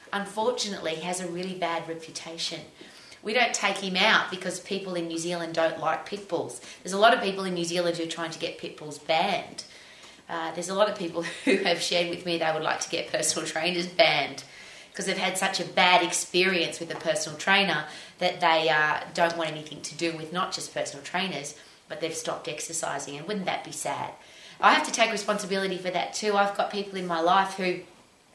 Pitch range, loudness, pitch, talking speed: 160-190 Hz, -26 LUFS, 175 Hz, 220 wpm